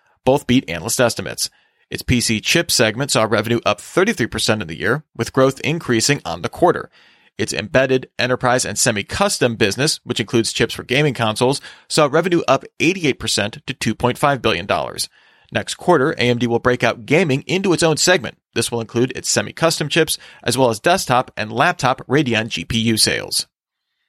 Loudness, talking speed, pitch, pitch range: -18 LUFS, 165 wpm, 125 Hz, 115-145 Hz